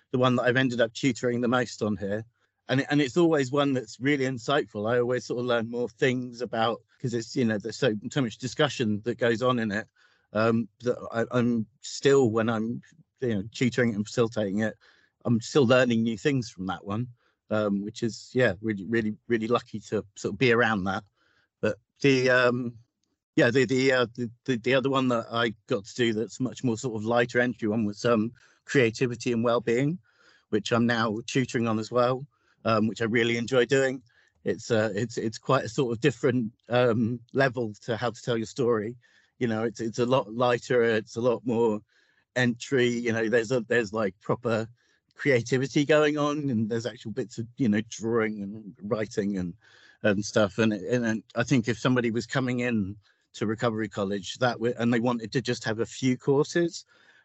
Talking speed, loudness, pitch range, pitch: 205 wpm, -27 LUFS, 110-125 Hz, 120 Hz